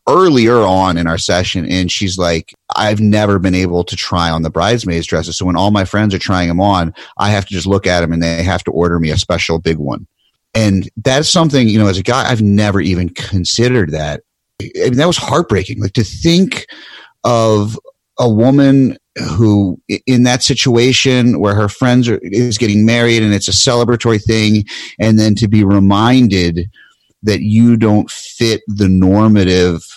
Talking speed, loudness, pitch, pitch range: 190 wpm, -12 LUFS, 105 Hz, 90-115 Hz